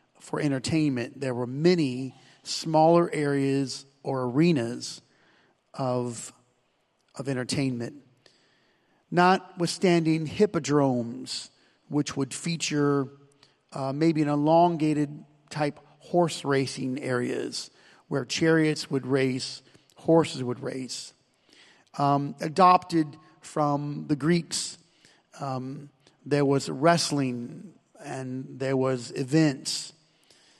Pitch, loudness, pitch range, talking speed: 140 Hz, -26 LUFS, 130-160 Hz, 90 wpm